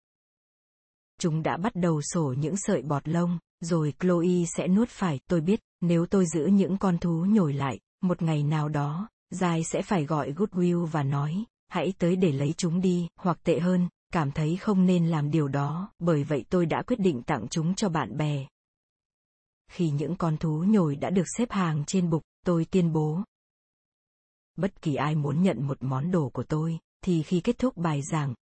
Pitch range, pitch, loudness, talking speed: 155-185 Hz, 170 Hz, -27 LUFS, 195 wpm